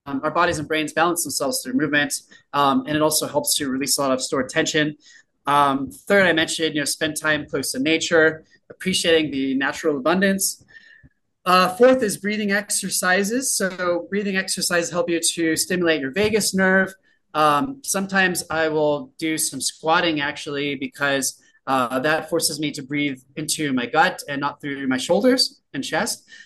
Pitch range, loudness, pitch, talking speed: 145-190 Hz, -21 LUFS, 160 Hz, 170 wpm